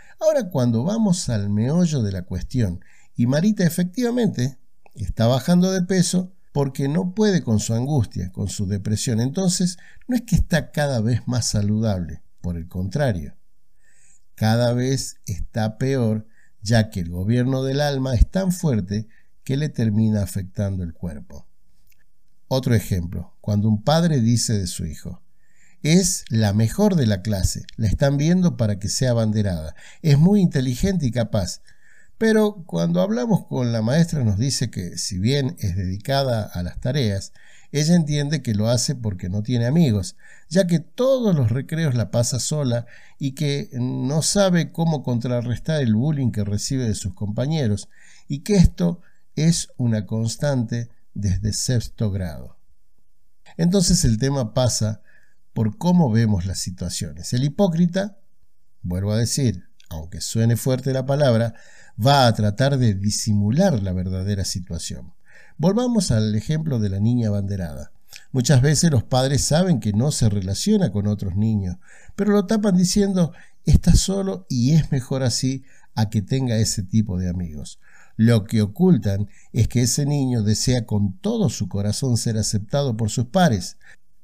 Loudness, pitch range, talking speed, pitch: -21 LUFS, 105-155 Hz, 155 wpm, 120 Hz